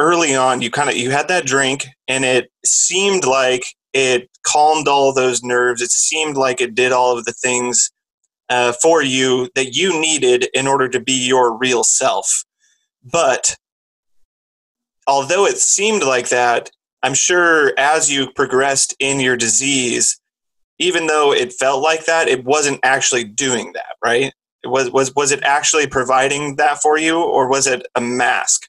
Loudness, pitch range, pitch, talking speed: -15 LUFS, 125-155 Hz, 135 Hz, 170 wpm